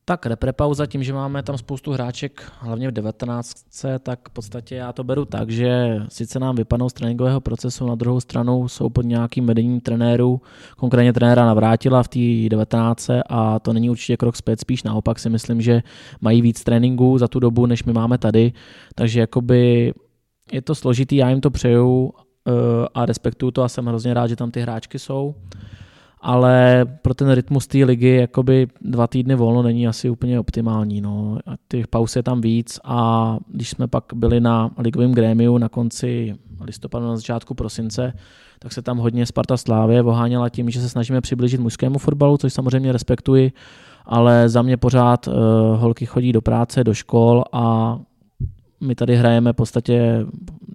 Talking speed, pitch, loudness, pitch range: 175 wpm, 120 Hz, -18 LUFS, 115-125 Hz